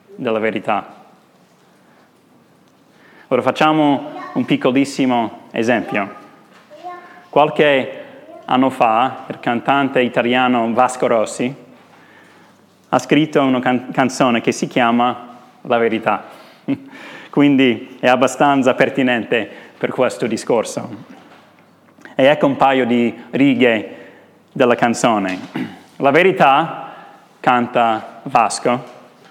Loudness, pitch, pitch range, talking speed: -16 LUFS, 130 Hz, 120-150 Hz, 90 wpm